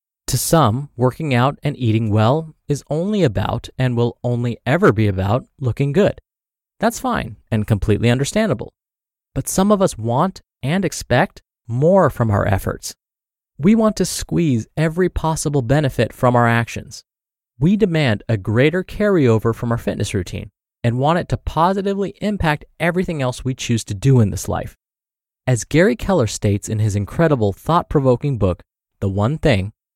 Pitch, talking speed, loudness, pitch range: 125 Hz, 160 wpm, -18 LUFS, 110-160 Hz